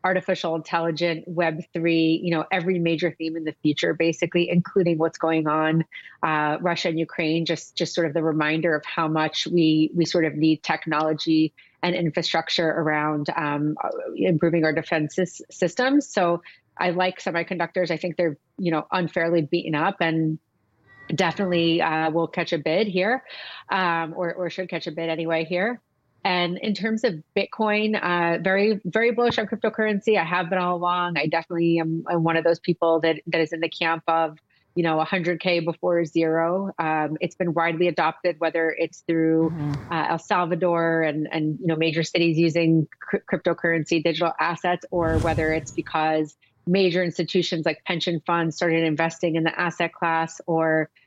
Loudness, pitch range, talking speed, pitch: -23 LUFS, 160-175 Hz, 175 wpm, 170 Hz